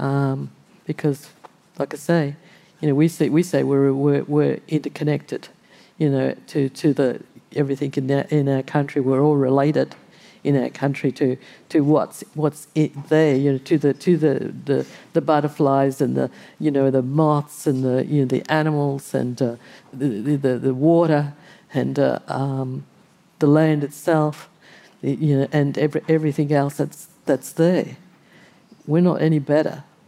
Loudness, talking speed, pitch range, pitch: -21 LUFS, 150 wpm, 140-155 Hz, 145 Hz